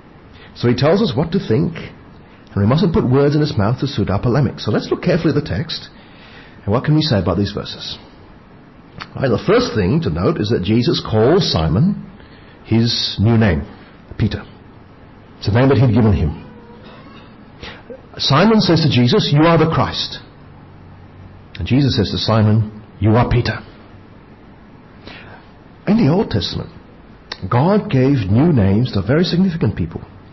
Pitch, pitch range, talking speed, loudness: 110 Hz, 100-135 Hz, 165 wpm, -16 LUFS